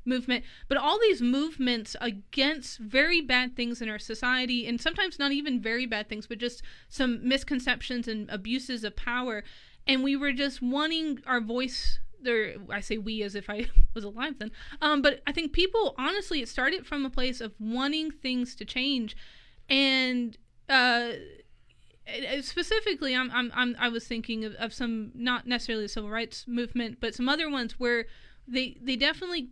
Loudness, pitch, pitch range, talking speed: -29 LUFS, 250 Hz, 230-275 Hz, 175 wpm